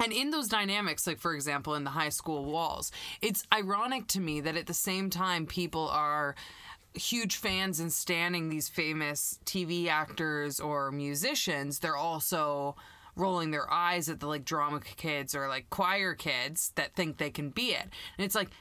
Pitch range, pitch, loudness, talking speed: 150-185 Hz, 165 Hz, -32 LUFS, 180 wpm